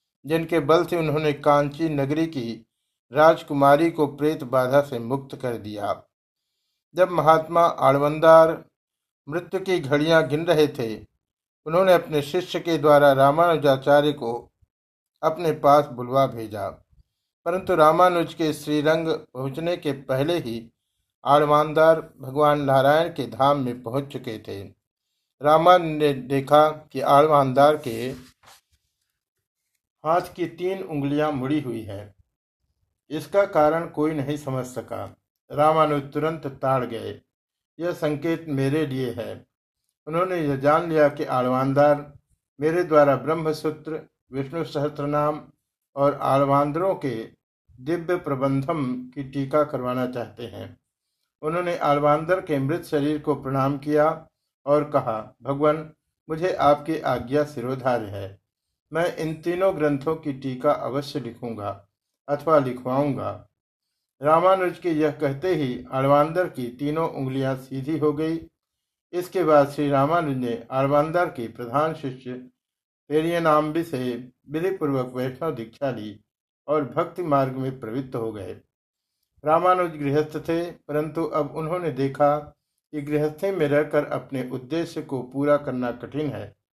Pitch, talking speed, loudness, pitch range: 145 Hz, 125 wpm, -22 LUFS, 130-160 Hz